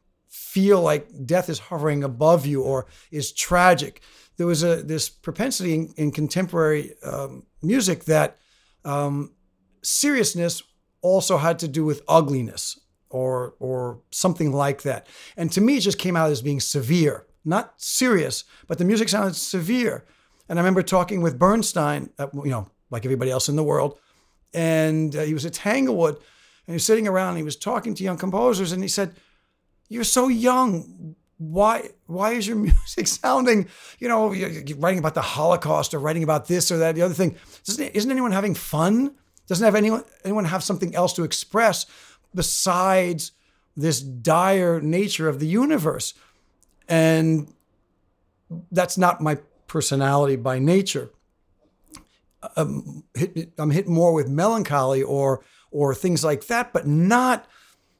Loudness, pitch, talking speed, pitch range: -22 LUFS, 170 Hz, 160 wpm, 150-195 Hz